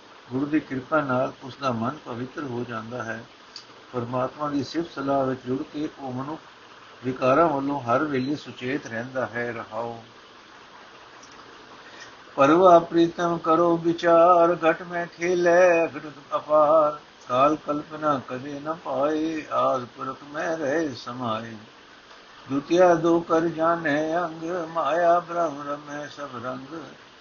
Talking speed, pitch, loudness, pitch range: 125 wpm, 145 Hz, -24 LUFS, 130-165 Hz